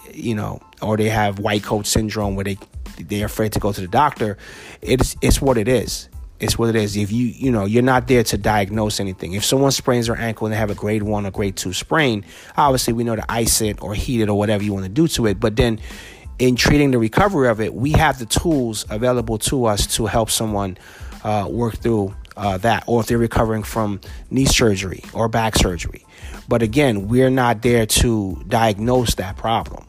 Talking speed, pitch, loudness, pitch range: 220 wpm, 110 Hz, -19 LUFS, 100-120 Hz